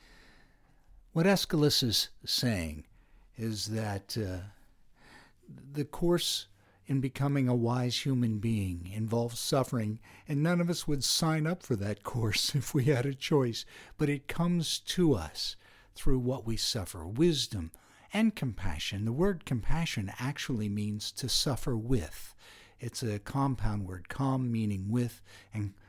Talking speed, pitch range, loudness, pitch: 140 wpm, 105-145 Hz, -31 LUFS, 120 Hz